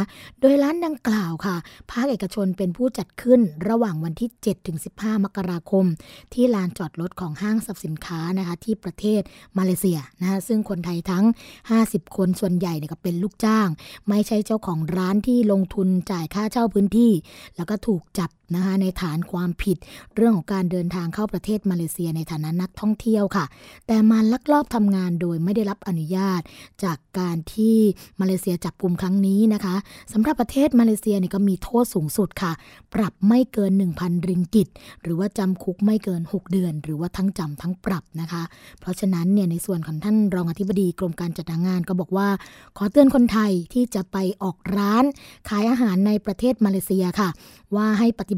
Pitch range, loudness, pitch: 180-215 Hz, -22 LUFS, 195 Hz